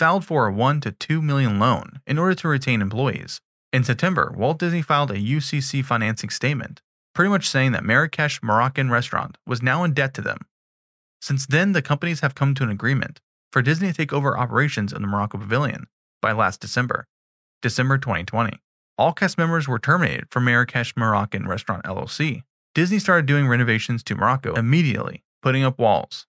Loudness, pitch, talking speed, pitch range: -21 LUFS, 130 Hz, 180 wpm, 115-150 Hz